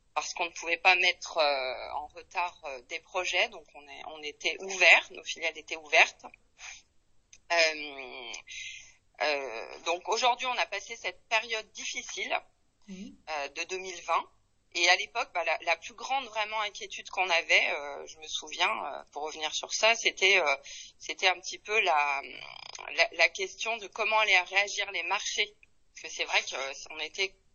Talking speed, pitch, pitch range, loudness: 175 wpm, 175 Hz, 155-210 Hz, -28 LUFS